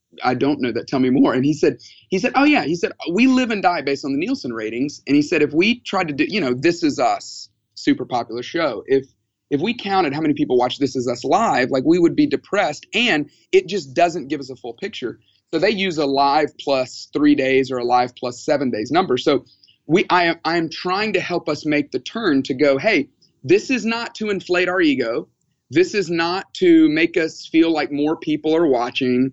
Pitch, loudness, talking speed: 160 Hz, -19 LUFS, 235 wpm